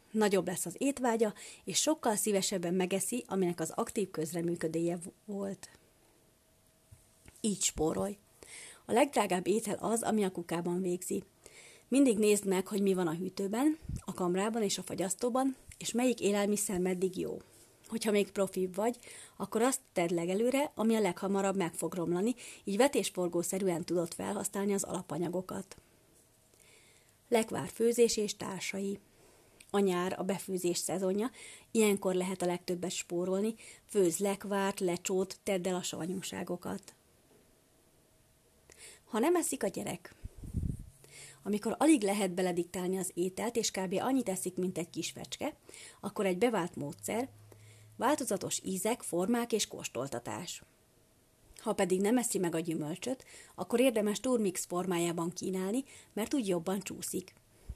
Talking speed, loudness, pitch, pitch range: 130 wpm, -33 LUFS, 195 Hz, 180-215 Hz